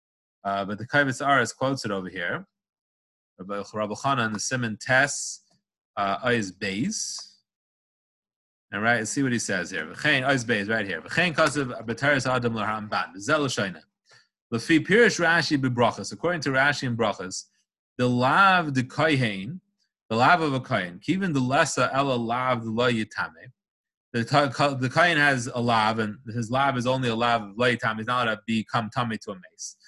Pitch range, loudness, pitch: 110-145 Hz, -24 LUFS, 125 Hz